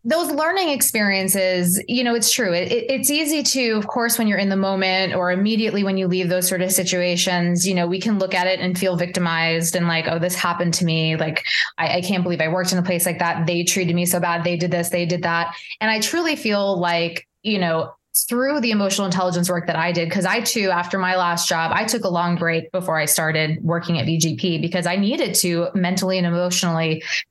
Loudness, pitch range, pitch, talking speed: -19 LUFS, 175-200 Hz, 180 Hz, 235 wpm